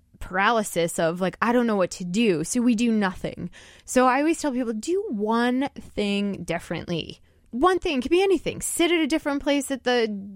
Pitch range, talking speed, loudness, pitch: 185-280 Hz, 205 wpm, -24 LUFS, 230 Hz